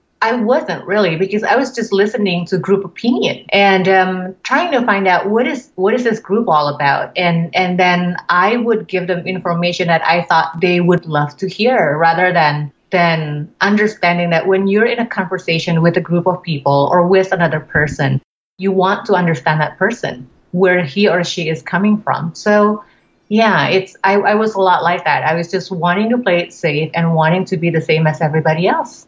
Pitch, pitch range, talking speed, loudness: 180 Hz, 165-200 Hz, 205 wpm, -14 LUFS